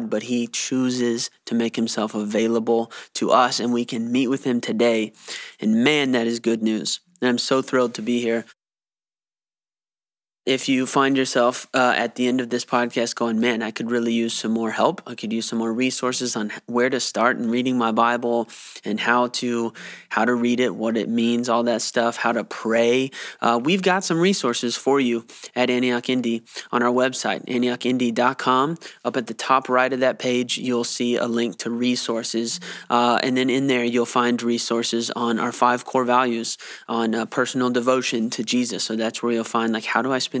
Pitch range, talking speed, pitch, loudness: 115-125 Hz, 200 wpm, 120 Hz, -22 LUFS